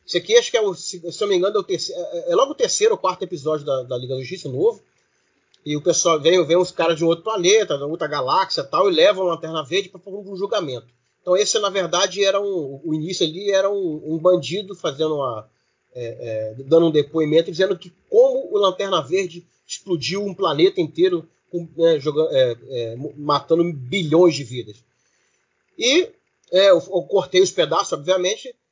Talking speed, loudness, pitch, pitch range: 205 wpm, -20 LUFS, 180 Hz, 160-210 Hz